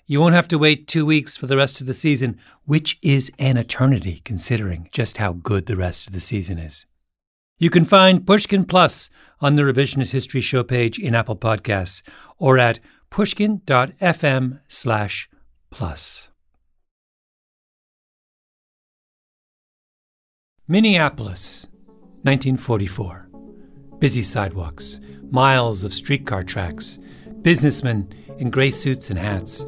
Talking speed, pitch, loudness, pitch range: 120 wpm, 130 Hz, -19 LUFS, 100-145 Hz